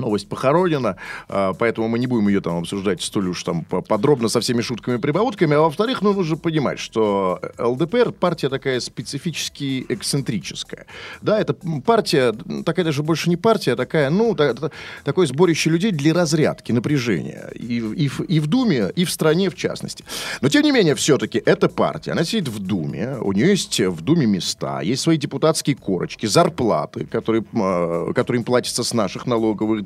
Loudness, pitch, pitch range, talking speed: -20 LUFS, 145 Hz, 115-175 Hz, 175 wpm